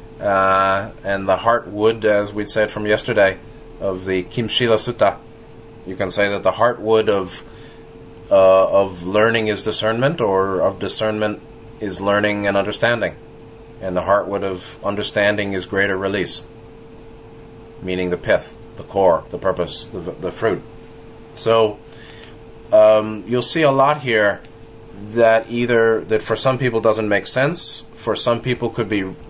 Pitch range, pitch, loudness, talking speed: 100-115 Hz, 110 Hz, -18 LUFS, 145 wpm